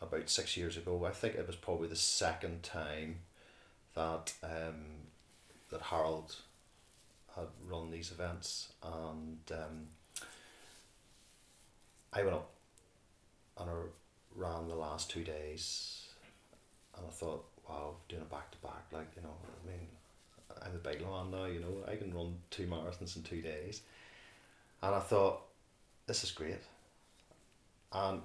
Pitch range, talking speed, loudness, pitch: 80-90 Hz, 145 wpm, -41 LUFS, 85 Hz